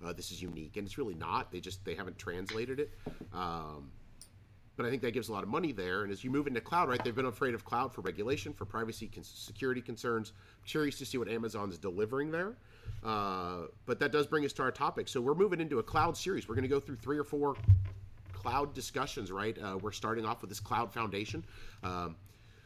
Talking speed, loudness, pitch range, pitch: 235 wpm, -36 LUFS, 95-125 Hz, 110 Hz